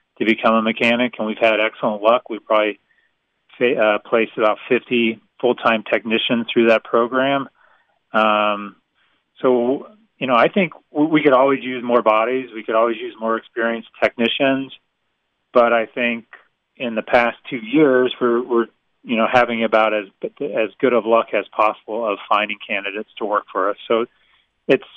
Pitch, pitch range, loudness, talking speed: 115 Hz, 110-125 Hz, -18 LUFS, 165 wpm